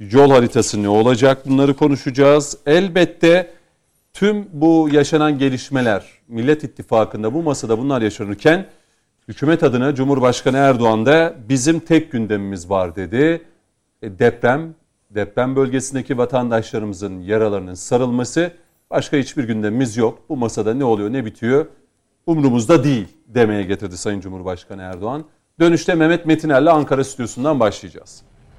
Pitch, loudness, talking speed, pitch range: 130 Hz, -17 LUFS, 120 wpm, 110-150 Hz